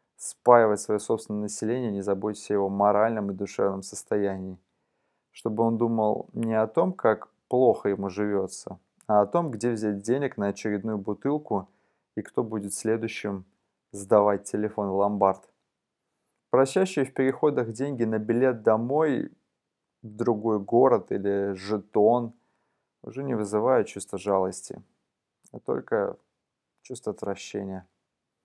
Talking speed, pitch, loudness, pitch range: 125 wpm, 105 Hz, -26 LUFS, 100-115 Hz